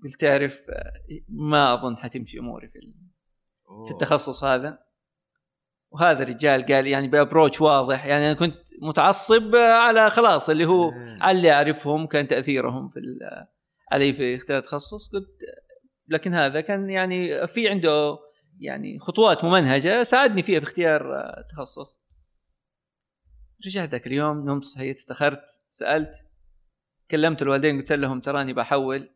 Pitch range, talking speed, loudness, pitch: 135-180 Hz, 125 wpm, -21 LUFS, 150 Hz